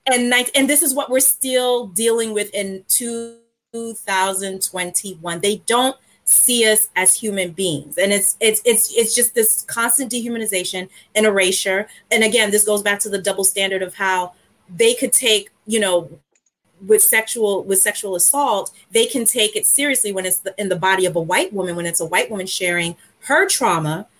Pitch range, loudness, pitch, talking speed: 190-235 Hz, -16 LUFS, 210 Hz, 185 wpm